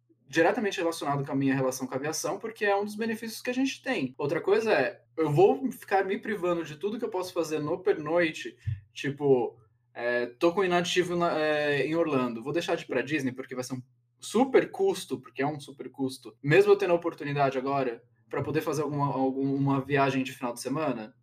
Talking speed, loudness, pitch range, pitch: 215 wpm, -28 LUFS, 130-185 Hz, 150 Hz